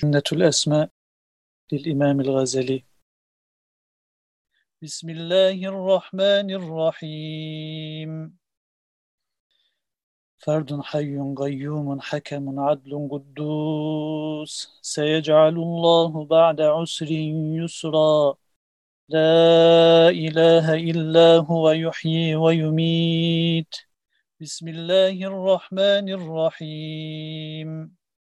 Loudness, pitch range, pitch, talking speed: -20 LUFS, 150-165 Hz, 155 Hz, 60 wpm